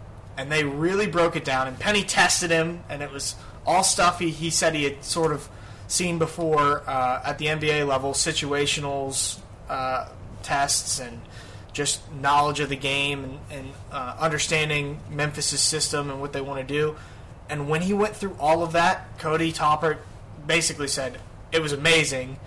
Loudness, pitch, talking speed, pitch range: -24 LUFS, 145 Hz, 170 wpm, 130-160 Hz